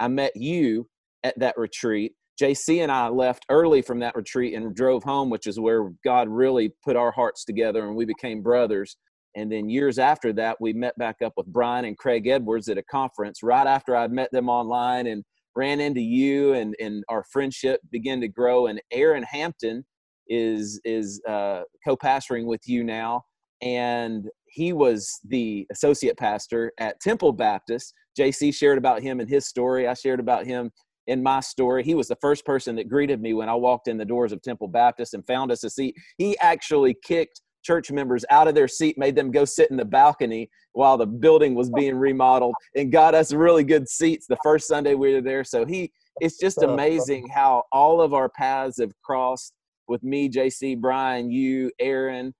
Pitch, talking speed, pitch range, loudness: 130 Hz, 195 wpm, 115-140 Hz, -23 LUFS